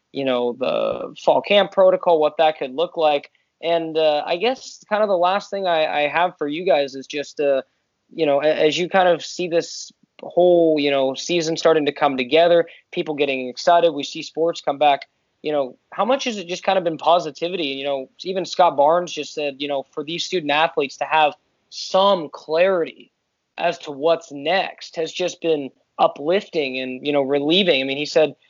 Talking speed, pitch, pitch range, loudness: 205 wpm, 160 Hz, 145-175 Hz, -20 LUFS